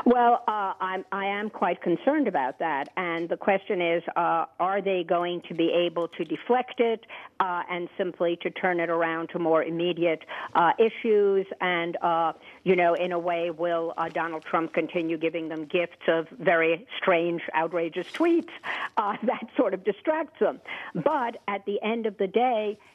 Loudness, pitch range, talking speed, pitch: -26 LUFS, 170-205 Hz, 180 wpm, 180 Hz